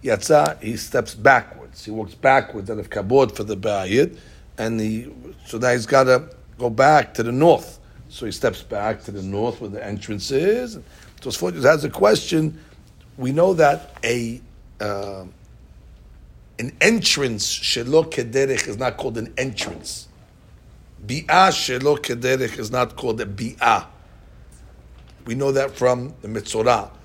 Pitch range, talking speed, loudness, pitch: 105-135 Hz, 150 wpm, -20 LUFS, 115 Hz